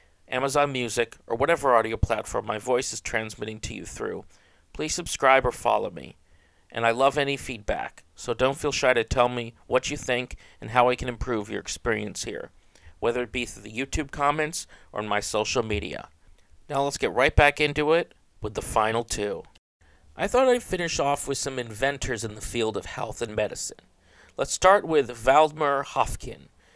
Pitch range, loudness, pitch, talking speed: 110-140 Hz, -25 LUFS, 125 Hz, 190 wpm